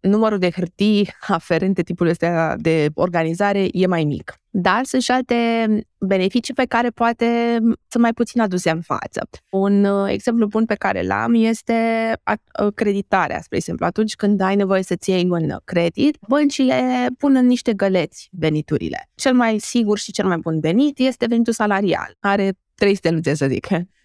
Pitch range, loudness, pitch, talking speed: 180-235 Hz, -19 LUFS, 200 Hz, 165 wpm